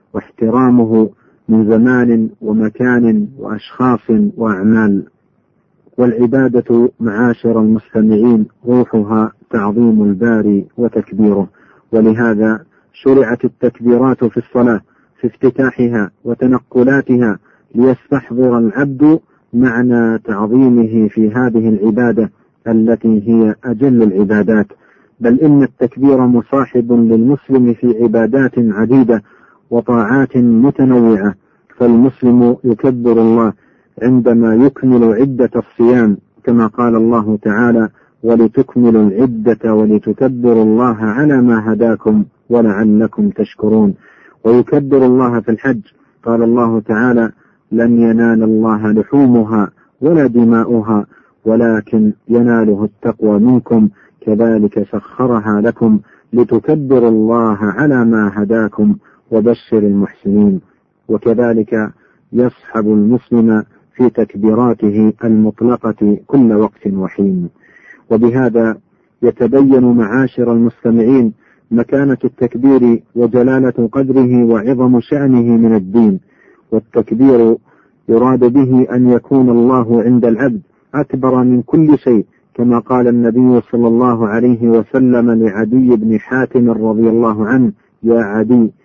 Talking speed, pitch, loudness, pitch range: 95 wpm, 115 Hz, -12 LUFS, 110-125 Hz